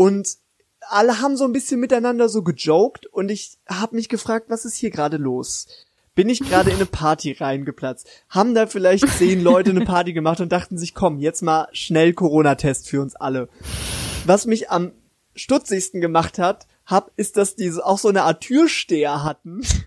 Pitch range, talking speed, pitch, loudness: 160-225 Hz, 180 wpm, 185 Hz, -19 LUFS